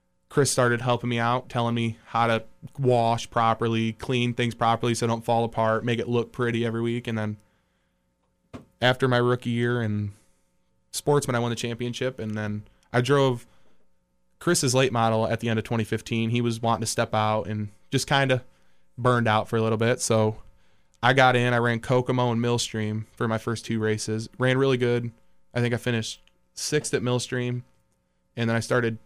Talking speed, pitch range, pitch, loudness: 190 wpm, 110-120 Hz, 115 Hz, -25 LUFS